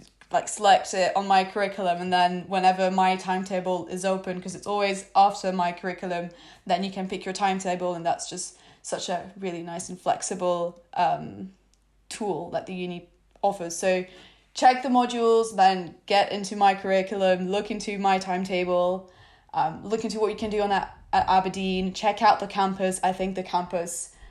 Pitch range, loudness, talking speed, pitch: 180-195 Hz, -25 LUFS, 180 wpm, 185 Hz